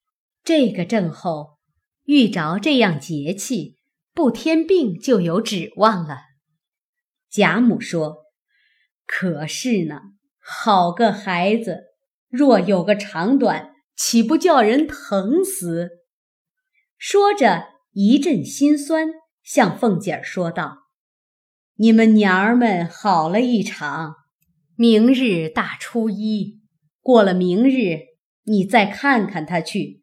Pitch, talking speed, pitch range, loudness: 215 Hz, 150 characters per minute, 175-270 Hz, -18 LUFS